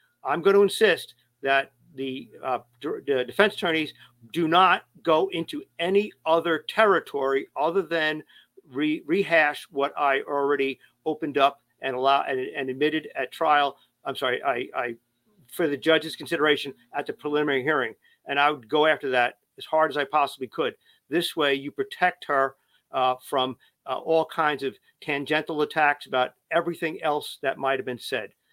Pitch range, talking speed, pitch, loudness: 135-165 Hz, 165 wpm, 150 Hz, -25 LUFS